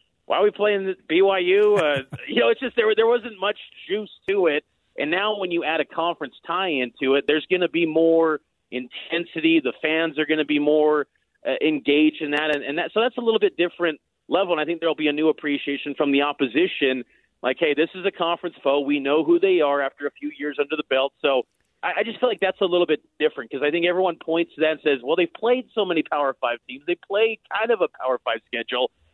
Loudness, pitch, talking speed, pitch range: -22 LUFS, 165 Hz, 245 wpm, 145-200 Hz